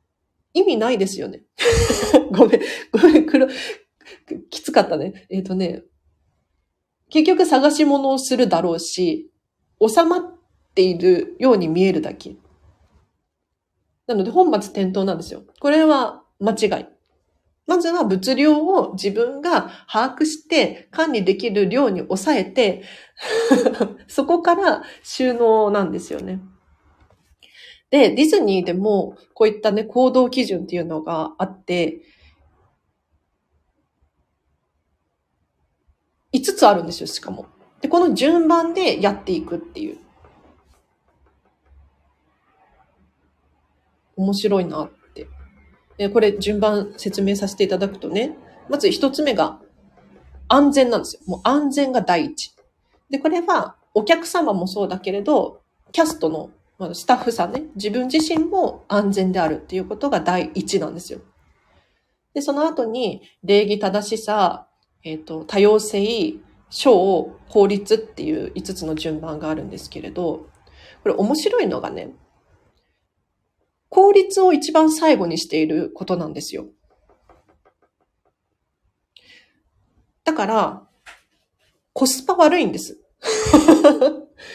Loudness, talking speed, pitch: -19 LUFS, 230 characters per minute, 210 Hz